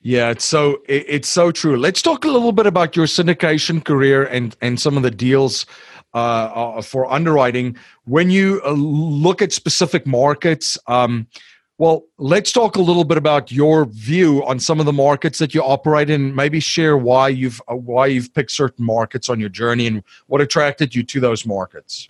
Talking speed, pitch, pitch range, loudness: 185 wpm, 145 Hz, 125-160 Hz, -16 LUFS